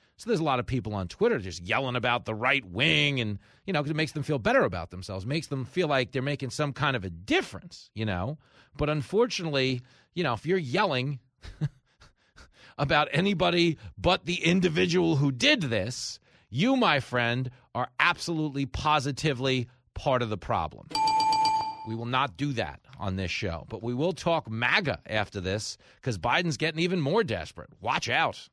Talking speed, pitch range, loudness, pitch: 180 wpm, 115-160 Hz, -27 LUFS, 135 Hz